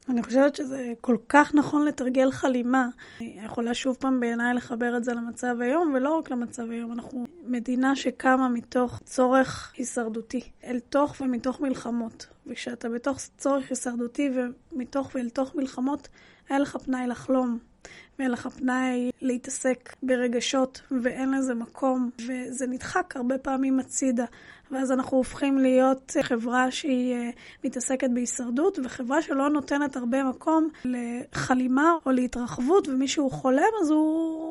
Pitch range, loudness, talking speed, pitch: 245-275 Hz, -26 LUFS, 135 wpm, 260 Hz